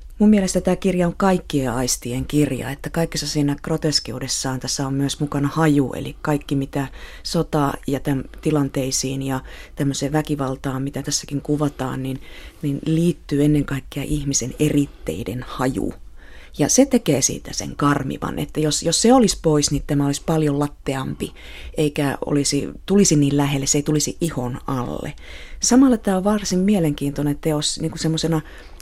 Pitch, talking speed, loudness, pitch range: 145 Hz, 150 wpm, -21 LUFS, 140-160 Hz